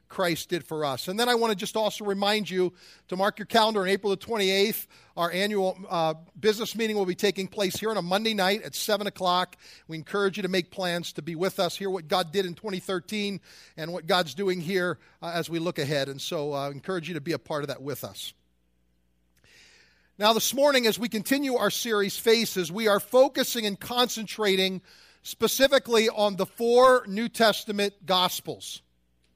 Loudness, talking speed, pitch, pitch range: -26 LUFS, 200 wpm, 195 Hz, 175-215 Hz